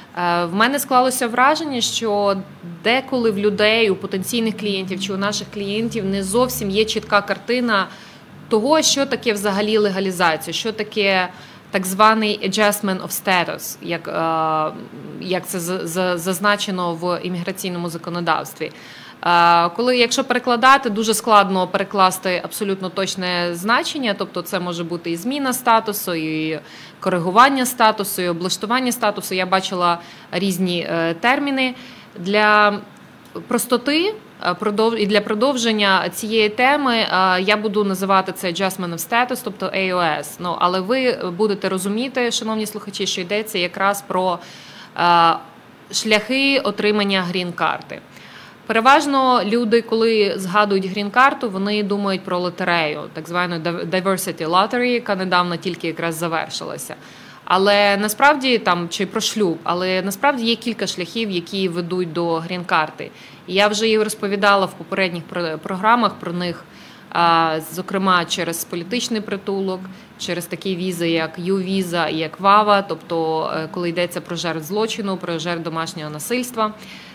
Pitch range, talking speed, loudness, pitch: 180-220 Hz, 125 wpm, -19 LUFS, 195 Hz